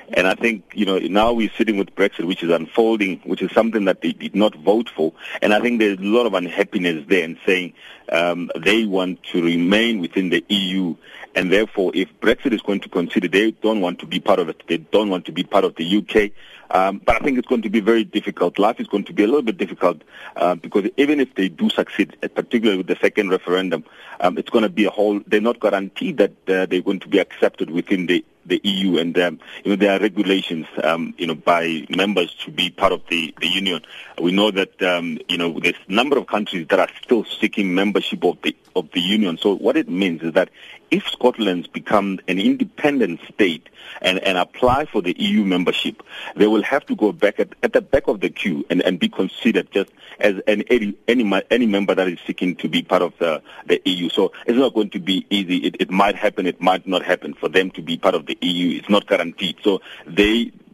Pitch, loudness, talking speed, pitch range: 100 Hz, -19 LUFS, 235 wpm, 90-110 Hz